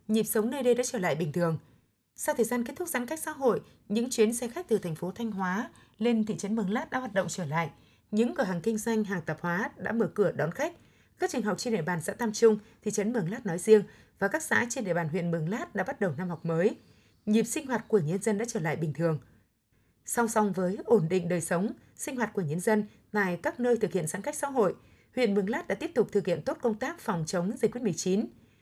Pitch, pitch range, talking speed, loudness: 210 Hz, 180-235 Hz, 265 wpm, -30 LUFS